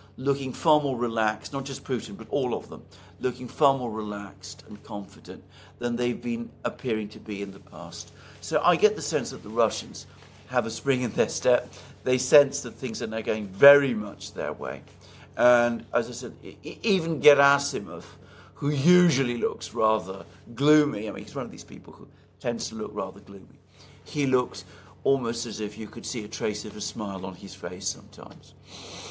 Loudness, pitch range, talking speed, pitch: -26 LUFS, 100-135 Hz, 190 wpm, 115 Hz